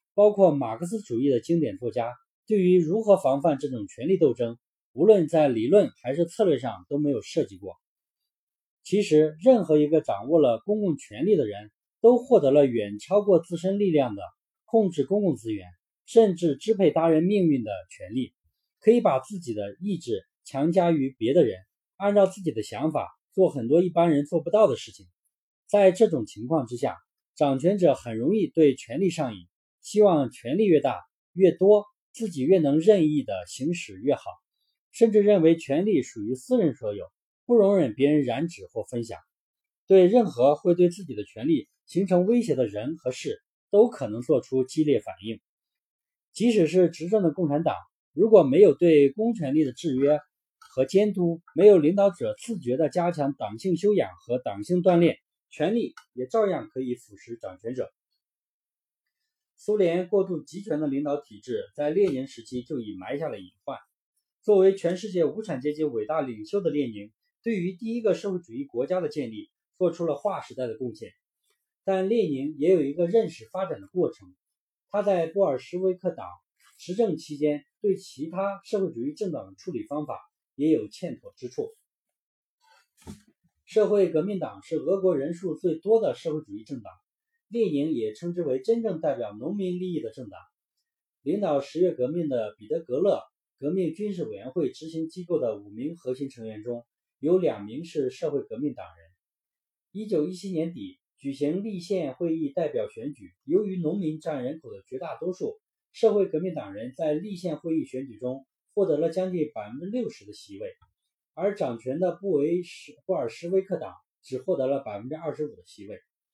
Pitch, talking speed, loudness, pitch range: 175 Hz, 270 characters per minute, -25 LUFS, 145-205 Hz